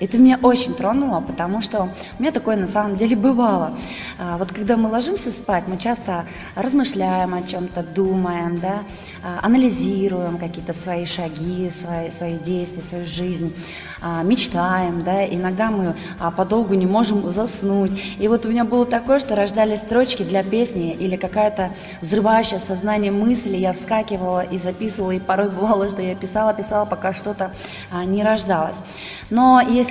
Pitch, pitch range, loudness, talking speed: 195 Hz, 180-220 Hz, -20 LUFS, 150 wpm